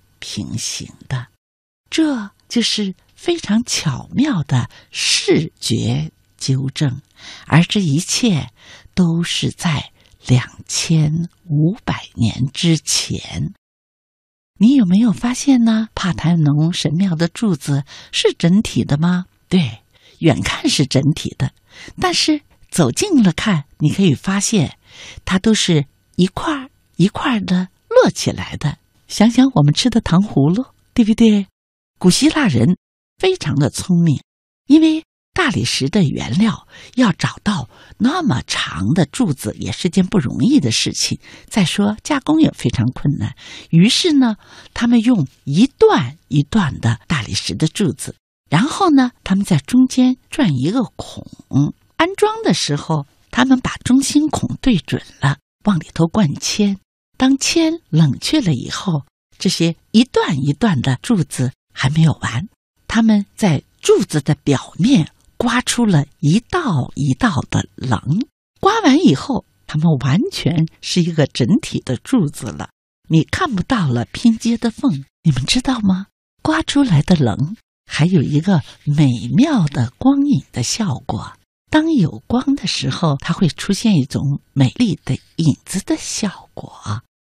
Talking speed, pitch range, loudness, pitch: 200 characters per minute, 140-235 Hz, -17 LUFS, 175 Hz